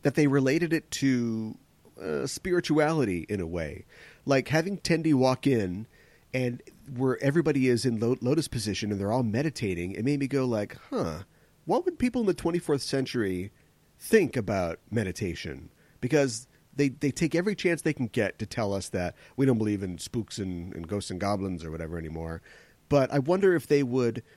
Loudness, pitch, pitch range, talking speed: -28 LUFS, 130 Hz, 105-150 Hz, 185 wpm